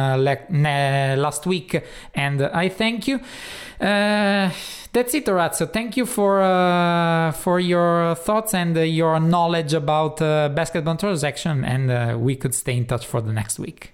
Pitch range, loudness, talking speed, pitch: 140-190 Hz, -21 LUFS, 175 wpm, 165 Hz